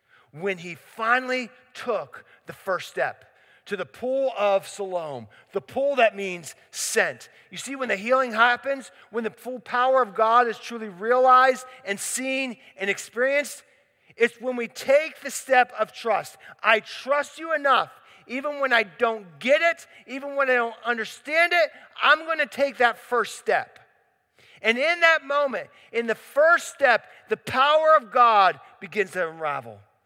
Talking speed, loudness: 165 wpm, -23 LUFS